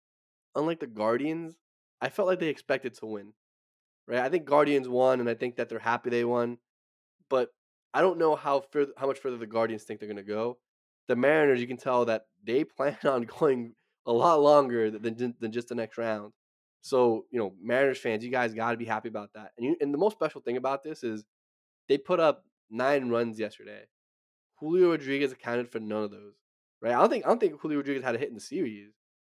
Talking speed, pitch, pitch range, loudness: 225 wpm, 120 Hz, 110-140 Hz, -28 LUFS